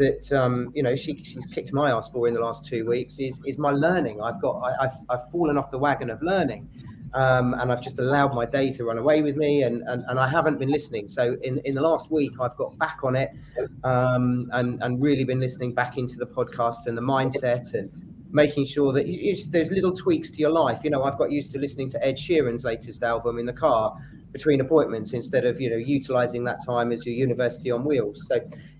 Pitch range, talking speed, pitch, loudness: 125-145 Hz, 235 wpm, 130 Hz, -25 LUFS